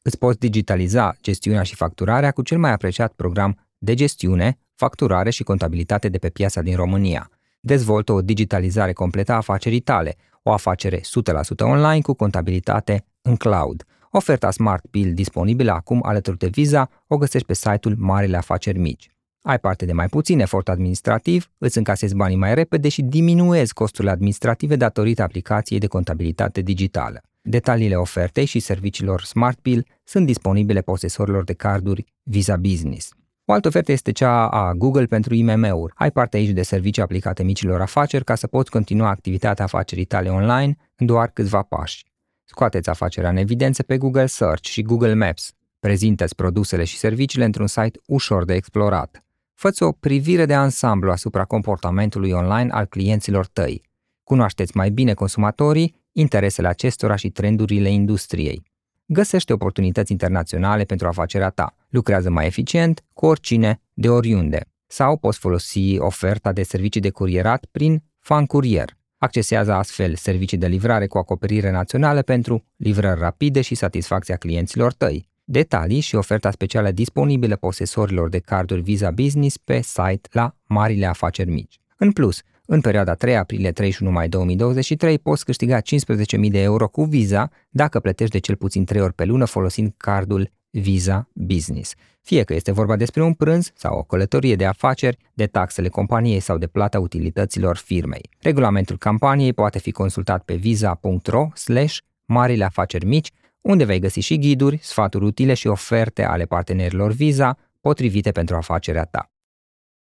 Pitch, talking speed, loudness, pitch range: 105 Hz, 155 wpm, -20 LUFS, 95-120 Hz